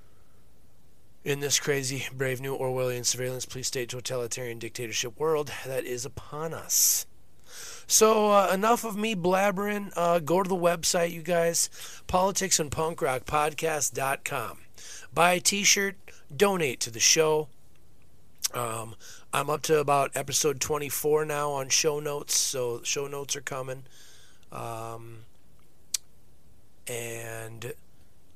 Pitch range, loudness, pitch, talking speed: 120-170 Hz, -26 LUFS, 140 Hz, 120 wpm